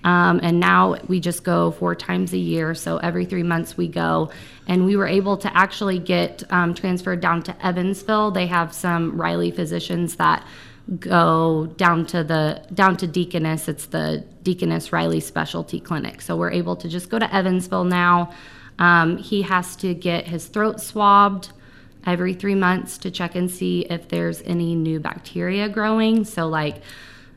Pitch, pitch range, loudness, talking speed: 175 Hz, 160-185 Hz, -21 LUFS, 175 wpm